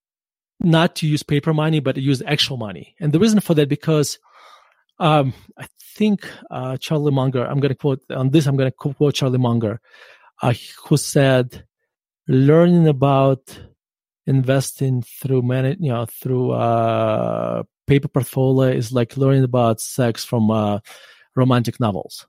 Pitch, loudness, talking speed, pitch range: 135 Hz, -19 LUFS, 155 wpm, 125-150 Hz